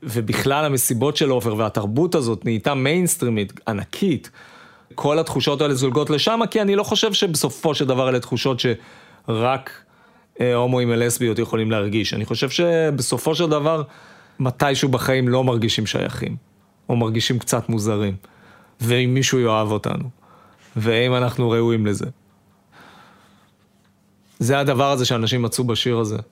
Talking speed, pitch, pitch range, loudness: 130 wpm, 125 Hz, 115-145 Hz, -20 LUFS